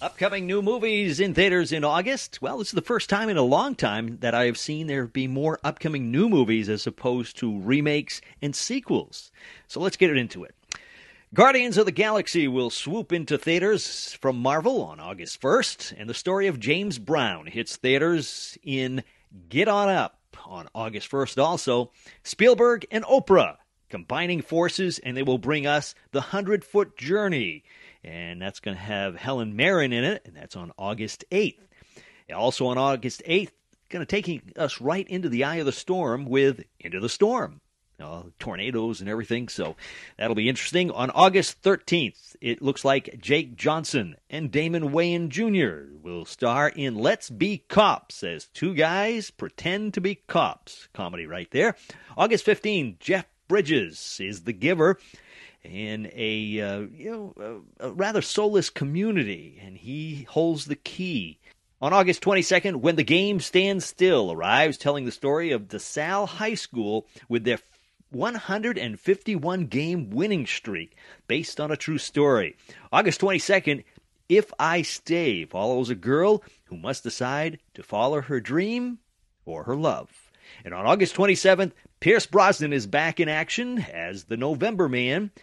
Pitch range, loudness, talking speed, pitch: 125-190 Hz, -24 LUFS, 165 wpm, 155 Hz